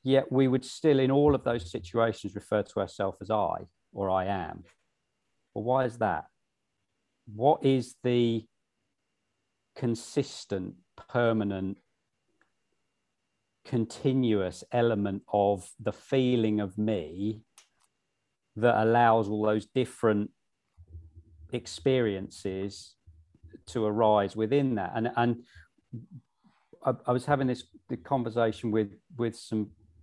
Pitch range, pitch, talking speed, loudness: 100-125 Hz, 110 Hz, 110 wpm, -29 LUFS